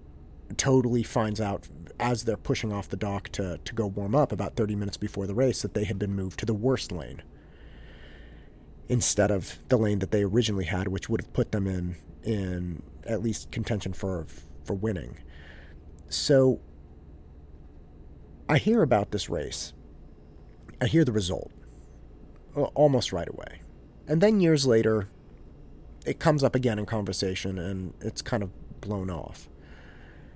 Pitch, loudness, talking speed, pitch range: 95 Hz, -28 LUFS, 160 wpm, 75-110 Hz